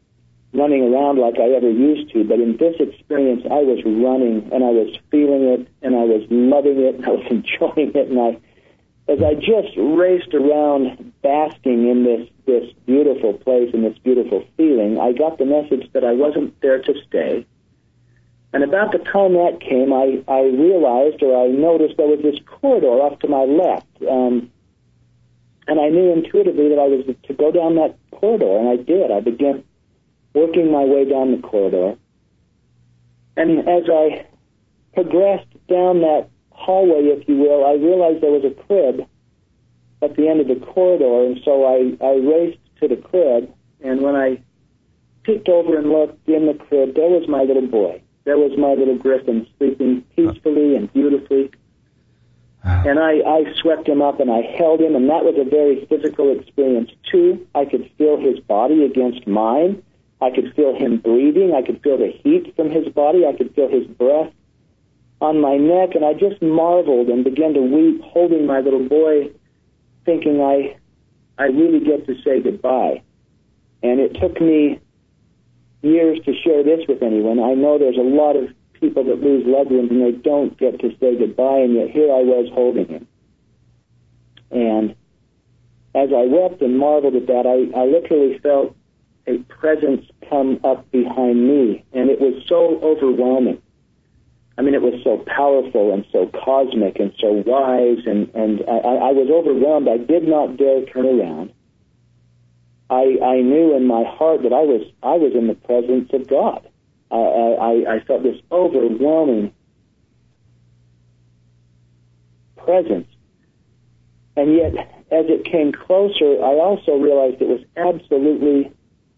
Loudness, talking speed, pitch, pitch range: -16 LUFS, 170 wpm, 135 Hz, 120-155 Hz